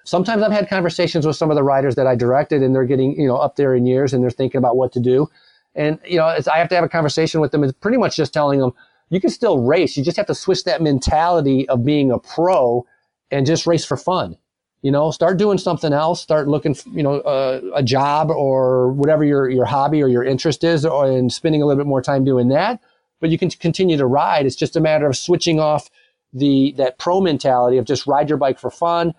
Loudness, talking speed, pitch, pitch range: -17 LUFS, 255 wpm, 145 Hz, 135-165 Hz